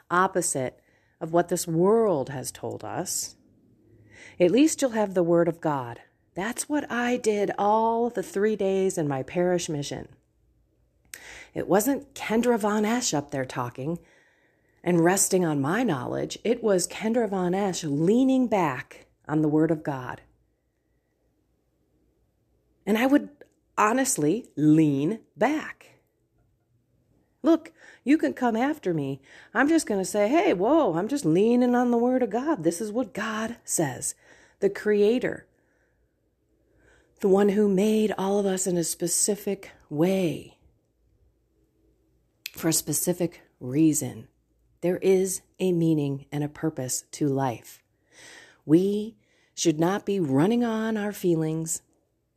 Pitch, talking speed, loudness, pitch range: 180 Hz, 135 wpm, -25 LUFS, 155-220 Hz